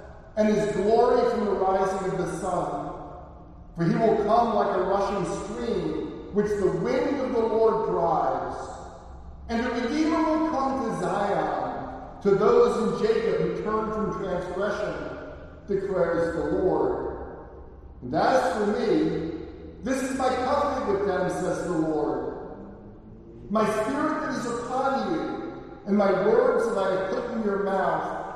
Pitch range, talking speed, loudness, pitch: 190-260 Hz, 150 wpm, -25 LUFS, 215 Hz